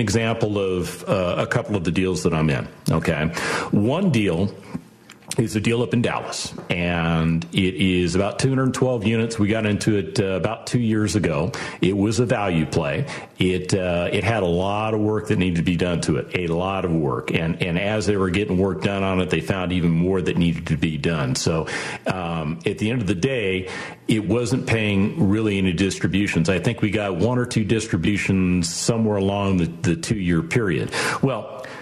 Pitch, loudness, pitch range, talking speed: 95 Hz, -22 LUFS, 90-110 Hz, 205 wpm